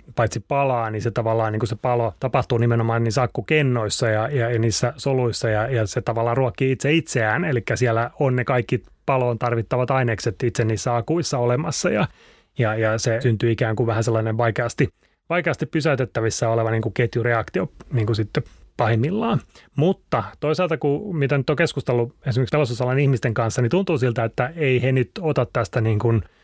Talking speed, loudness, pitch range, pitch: 175 wpm, -22 LUFS, 115-140 Hz, 120 Hz